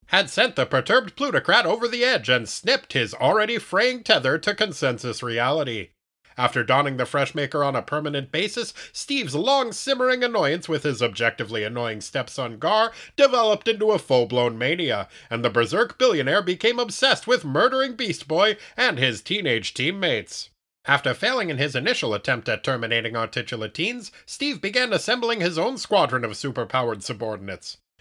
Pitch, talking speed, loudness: 160 Hz, 160 wpm, -22 LUFS